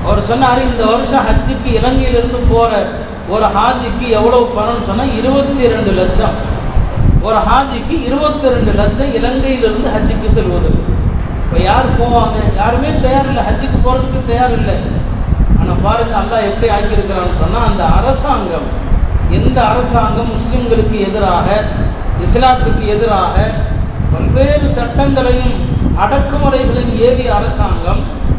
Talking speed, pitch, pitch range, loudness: 110 wpm, 240 Hz, 215-255 Hz, -13 LUFS